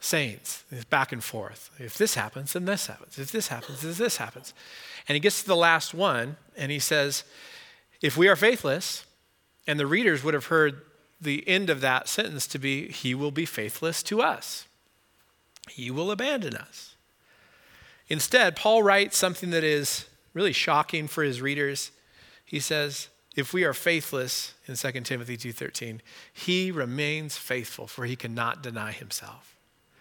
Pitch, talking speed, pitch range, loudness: 150 Hz, 165 wpm, 130-175 Hz, -26 LUFS